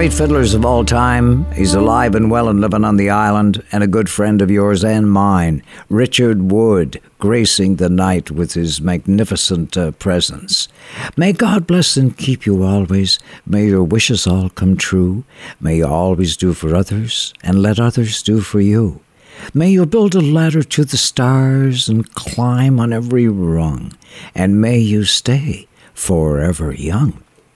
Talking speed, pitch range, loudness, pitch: 165 wpm, 95-120 Hz, -14 LUFS, 105 Hz